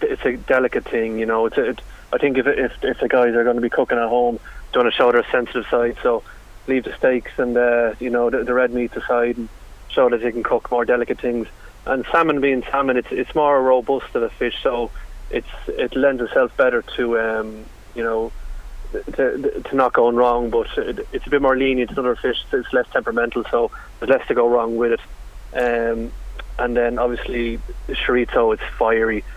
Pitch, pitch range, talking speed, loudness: 120 Hz, 115-135 Hz, 220 wpm, -20 LUFS